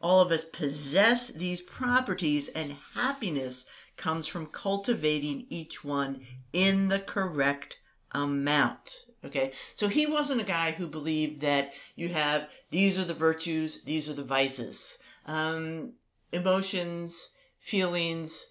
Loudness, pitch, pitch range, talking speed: -29 LUFS, 160 Hz, 145-185 Hz, 125 wpm